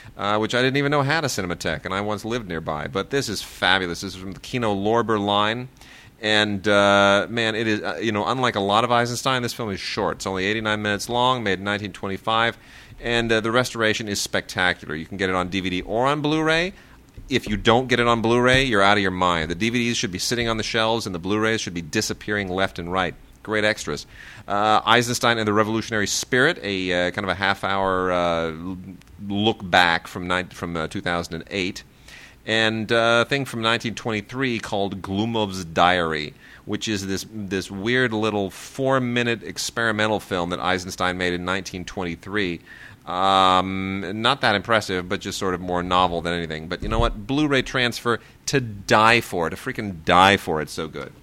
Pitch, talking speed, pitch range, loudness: 105 Hz, 200 wpm, 95-115 Hz, -22 LUFS